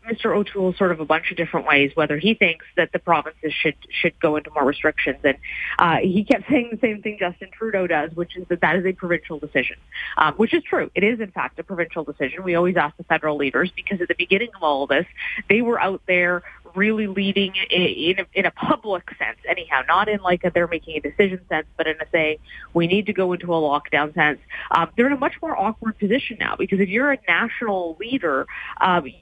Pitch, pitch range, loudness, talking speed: 180 Hz, 160-210 Hz, -21 LUFS, 240 wpm